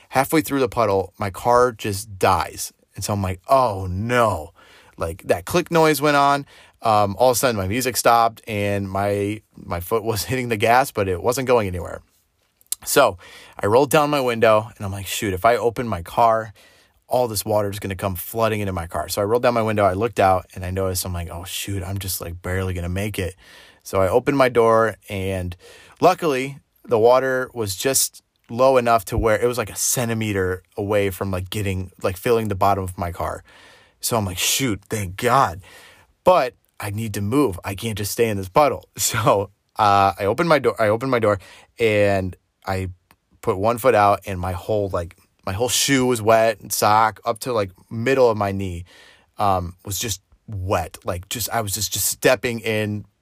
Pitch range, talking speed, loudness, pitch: 95-115 Hz, 205 wpm, -20 LUFS, 105 Hz